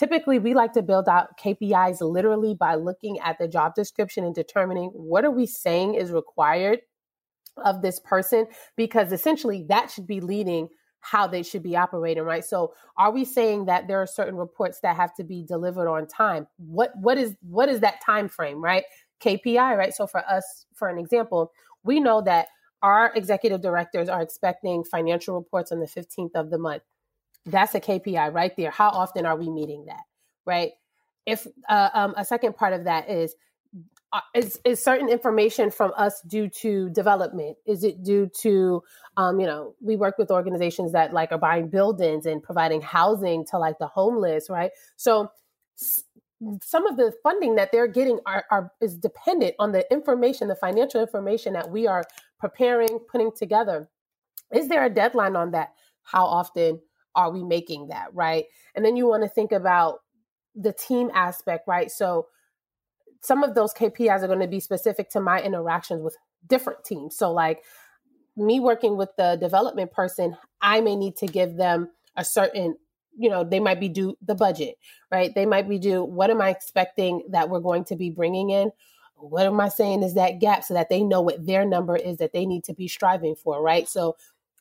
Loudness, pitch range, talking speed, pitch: -24 LUFS, 175-220 Hz, 190 wpm, 195 Hz